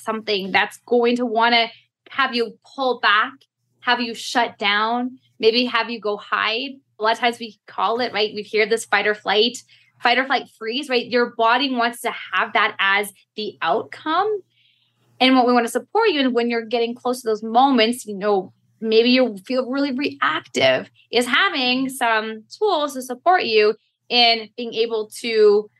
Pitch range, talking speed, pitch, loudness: 215-250 Hz, 185 wpm, 235 Hz, -19 LUFS